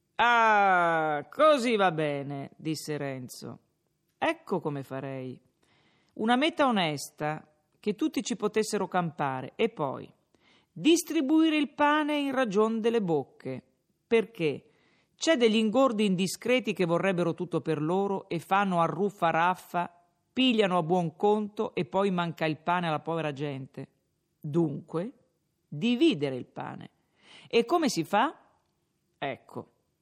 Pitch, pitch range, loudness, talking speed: 180 Hz, 155-230 Hz, -28 LUFS, 120 wpm